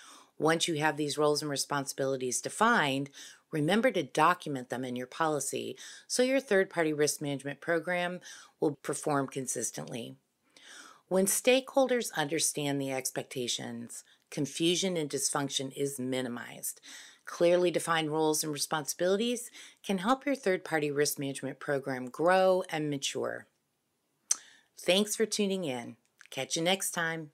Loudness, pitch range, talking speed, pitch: -30 LUFS, 140-180 Hz, 130 wpm, 155 Hz